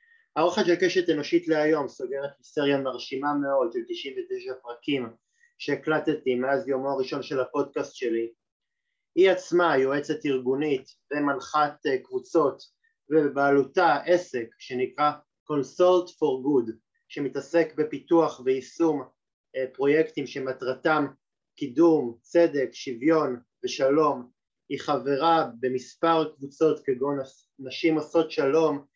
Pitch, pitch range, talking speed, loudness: 150 Hz, 135-170 Hz, 105 wpm, -26 LUFS